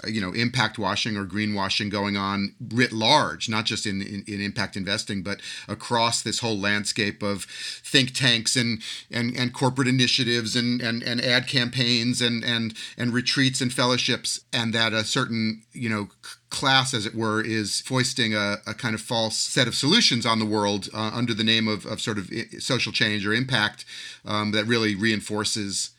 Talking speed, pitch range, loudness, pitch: 180 wpm, 105-125 Hz, -23 LUFS, 115 Hz